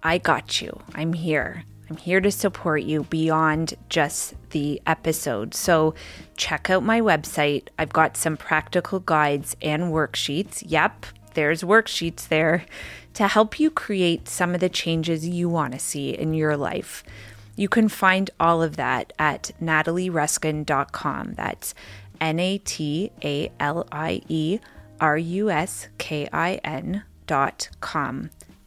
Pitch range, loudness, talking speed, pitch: 150-180 Hz, -23 LUFS, 120 wpm, 160 Hz